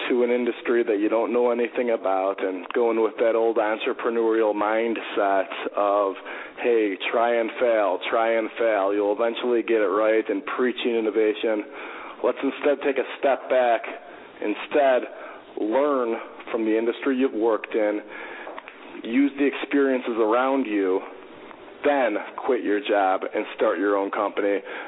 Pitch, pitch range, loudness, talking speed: 115 Hz, 105-120 Hz, -23 LUFS, 145 wpm